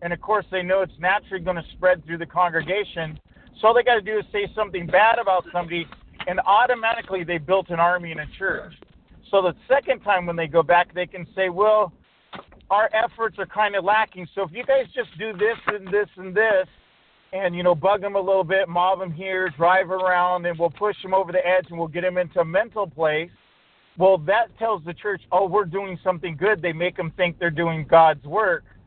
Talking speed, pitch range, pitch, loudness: 225 wpm, 175-210 Hz, 185 Hz, -22 LUFS